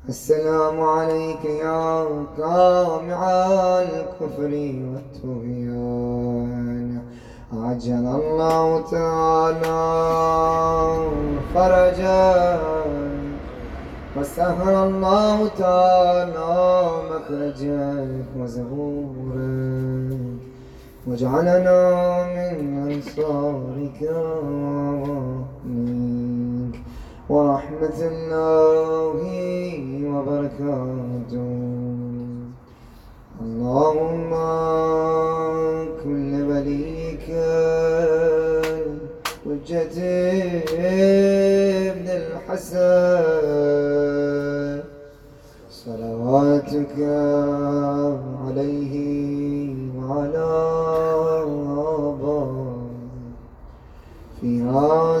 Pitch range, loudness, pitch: 130-160 Hz, -21 LUFS, 145 Hz